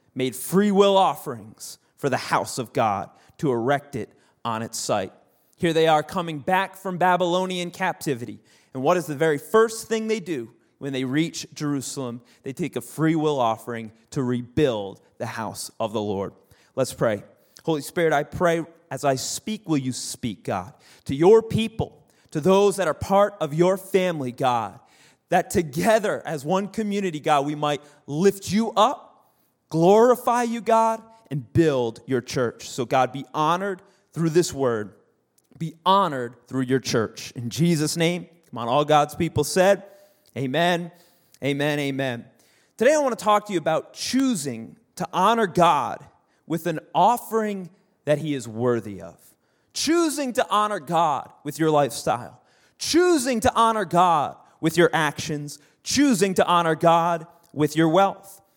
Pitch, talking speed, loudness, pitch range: 165 Hz, 160 wpm, -23 LUFS, 140-195 Hz